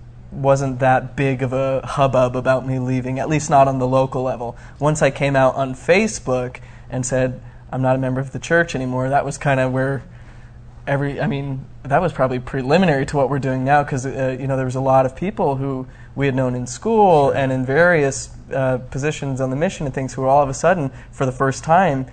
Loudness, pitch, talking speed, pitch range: -19 LUFS, 130 Hz, 230 wpm, 130-140 Hz